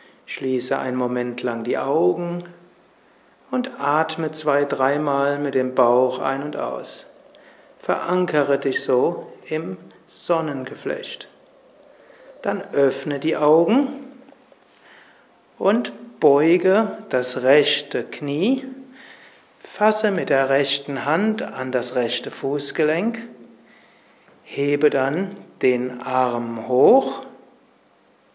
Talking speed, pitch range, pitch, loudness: 95 wpm, 130-180 Hz, 145 Hz, -21 LUFS